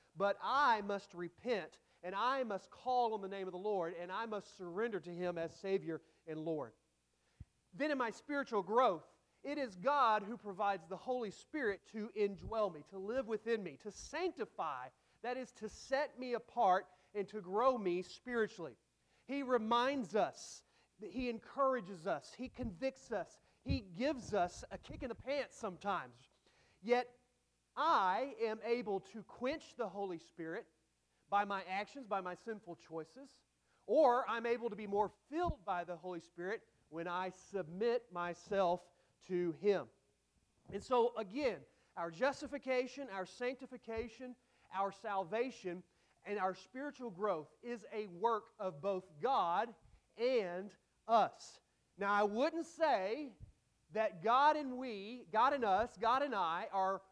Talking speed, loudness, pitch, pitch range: 150 wpm, -39 LUFS, 210 Hz, 185-245 Hz